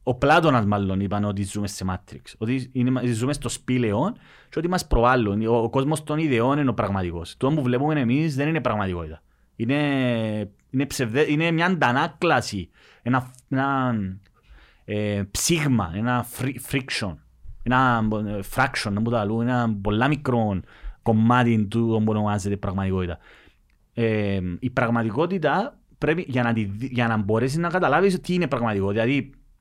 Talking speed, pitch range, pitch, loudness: 145 wpm, 105-135 Hz, 120 Hz, -23 LUFS